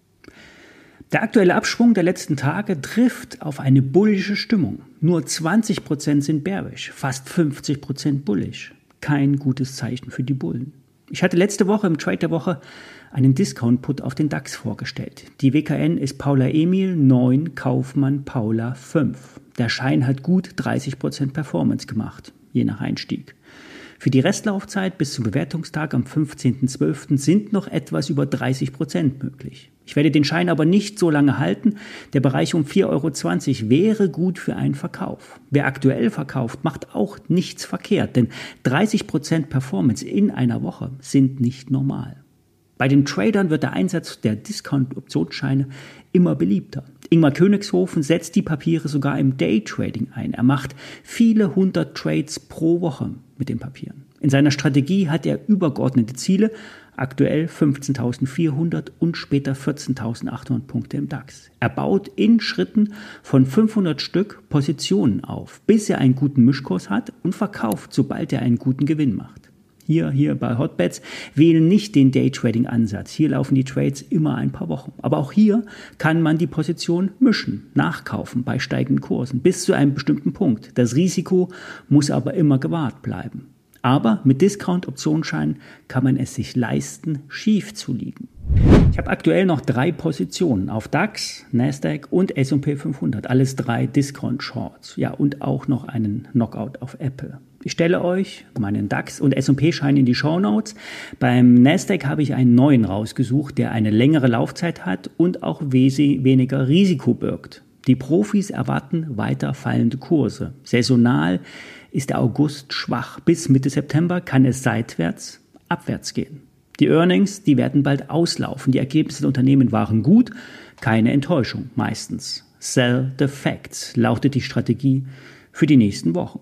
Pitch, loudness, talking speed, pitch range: 145 Hz, -20 LUFS, 150 wpm, 130-170 Hz